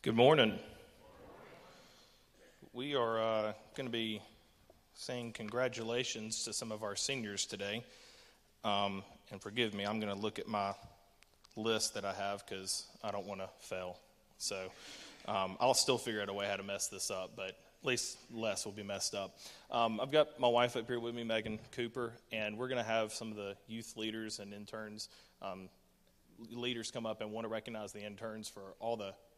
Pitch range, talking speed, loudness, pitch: 100-115 Hz, 190 wpm, -38 LUFS, 110 Hz